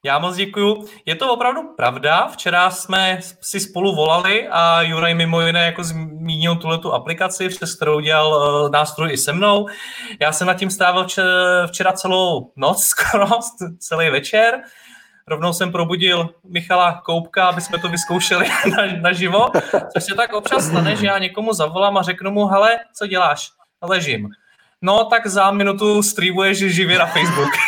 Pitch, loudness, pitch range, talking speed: 180 Hz, -17 LUFS, 170-195 Hz, 165 wpm